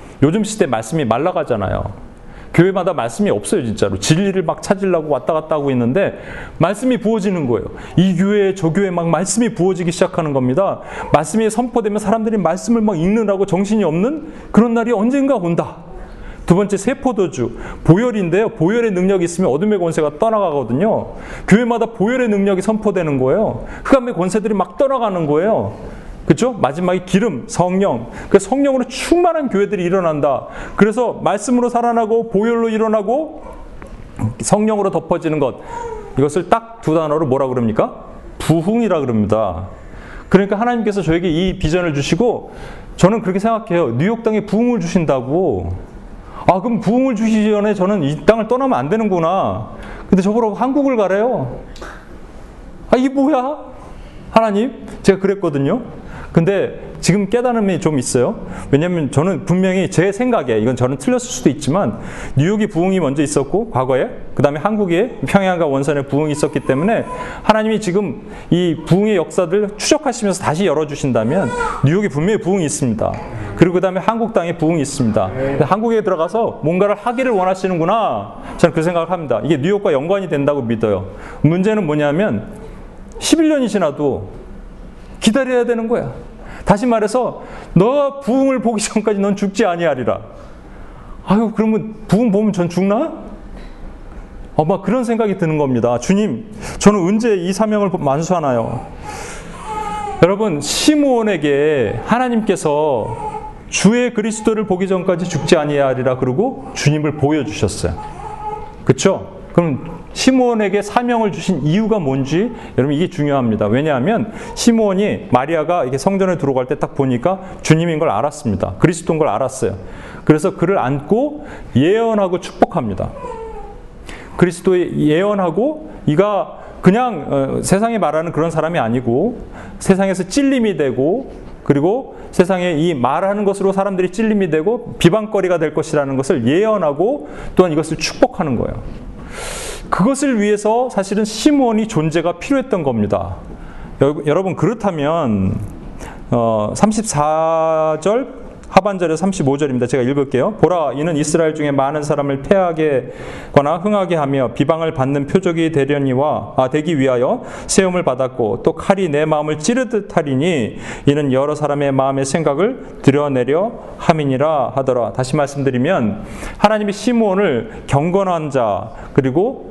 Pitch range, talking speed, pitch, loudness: 150-220 Hz, 340 characters per minute, 185 Hz, -16 LUFS